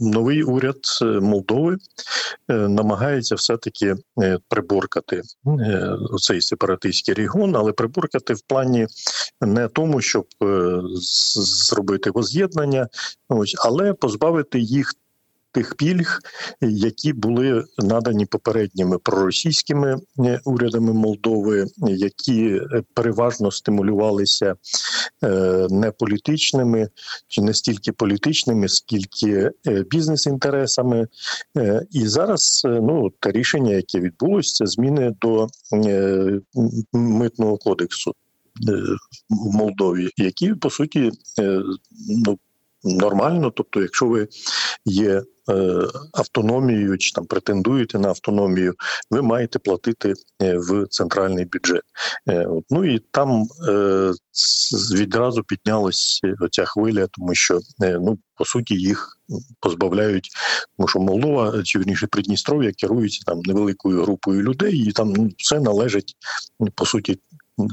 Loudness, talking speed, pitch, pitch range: -20 LUFS, 100 wpm, 110 Hz, 100-125 Hz